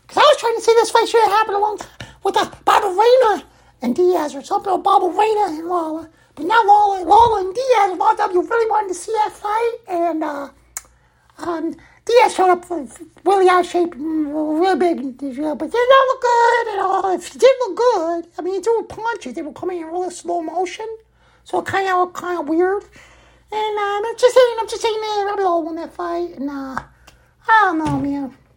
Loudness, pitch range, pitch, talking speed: -17 LUFS, 340-435 Hz, 385 Hz, 215 wpm